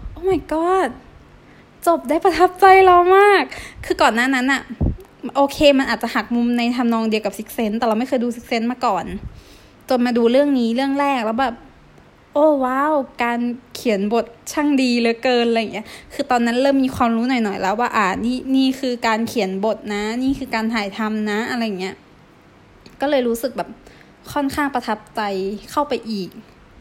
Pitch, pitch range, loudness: 245 Hz, 225-275 Hz, -18 LUFS